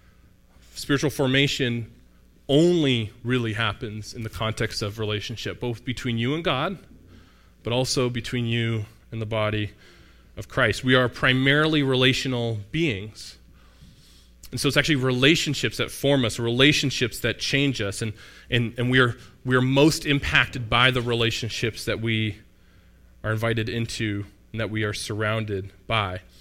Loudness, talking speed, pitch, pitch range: -23 LUFS, 145 wpm, 115 Hz, 105-130 Hz